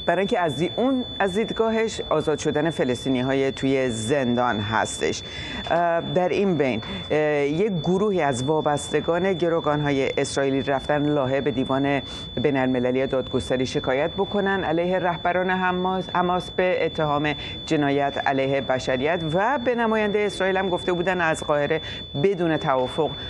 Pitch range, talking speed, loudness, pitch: 135-185 Hz, 125 wpm, -23 LUFS, 155 Hz